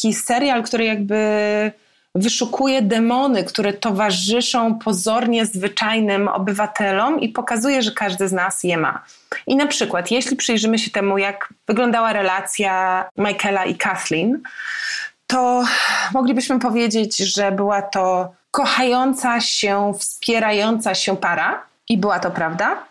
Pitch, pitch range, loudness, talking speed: 215 Hz, 200-245 Hz, -18 LUFS, 120 wpm